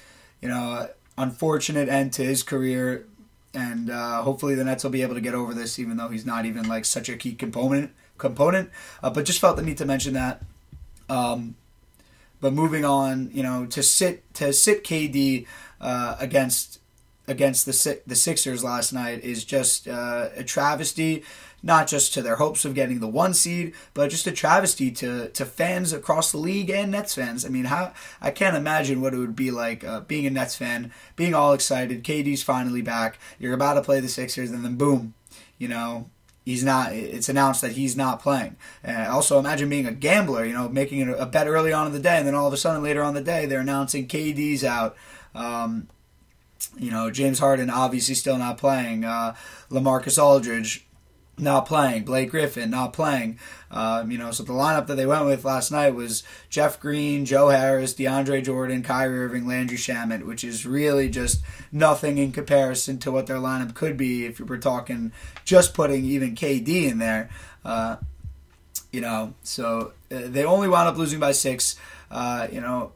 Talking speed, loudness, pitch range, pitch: 195 wpm, -23 LUFS, 120-145 Hz, 130 Hz